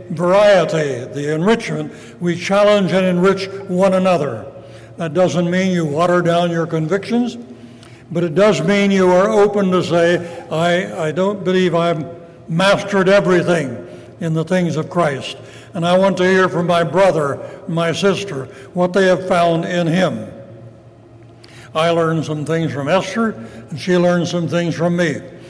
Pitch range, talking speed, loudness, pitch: 155-185 Hz, 160 wpm, -16 LUFS, 175 Hz